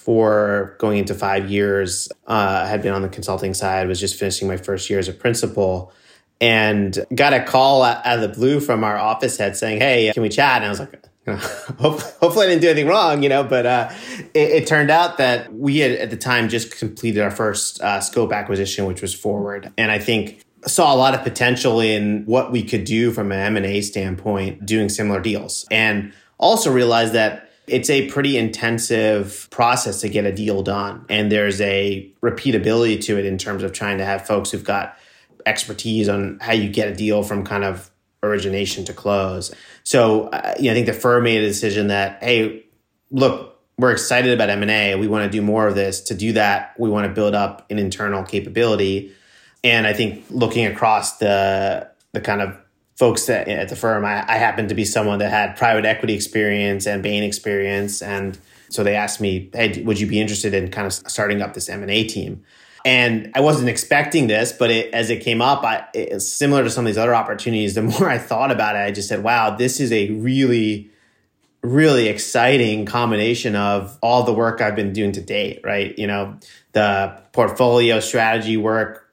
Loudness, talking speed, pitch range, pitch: -18 LUFS, 205 wpm, 100-115 Hz, 105 Hz